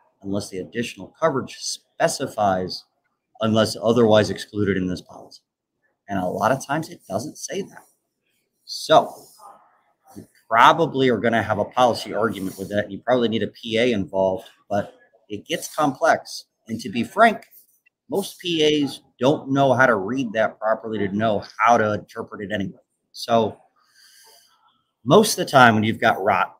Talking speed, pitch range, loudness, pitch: 160 wpm, 100-130 Hz, -21 LUFS, 110 Hz